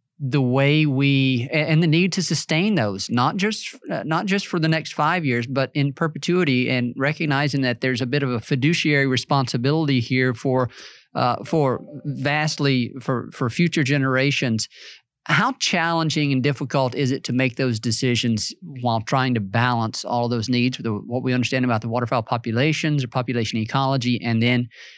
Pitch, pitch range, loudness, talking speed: 135 Hz, 125-150 Hz, -21 LUFS, 175 wpm